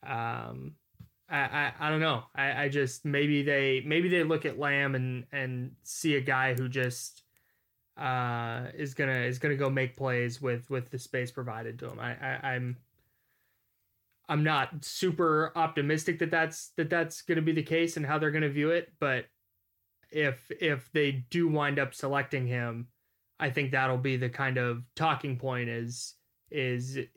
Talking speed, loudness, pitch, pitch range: 175 wpm, -30 LUFS, 135 Hz, 125-150 Hz